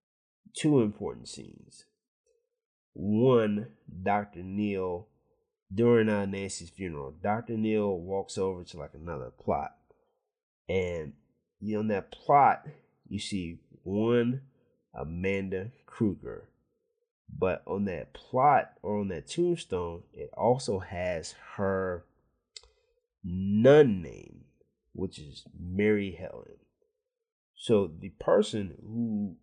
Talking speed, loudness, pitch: 105 wpm, -29 LUFS, 105 Hz